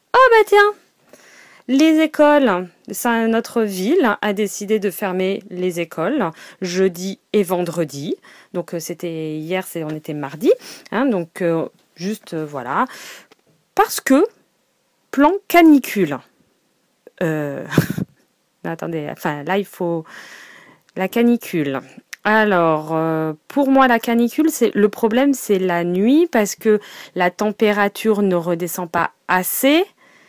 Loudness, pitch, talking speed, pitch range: -18 LUFS, 200 Hz, 125 wpm, 170-240 Hz